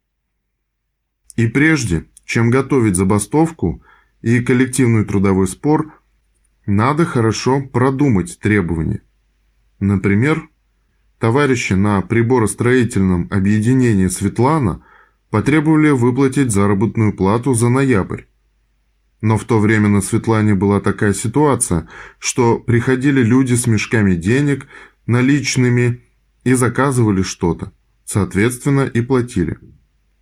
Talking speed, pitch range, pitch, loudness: 95 wpm, 100-130 Hz, 115 Hz, -16 LUFS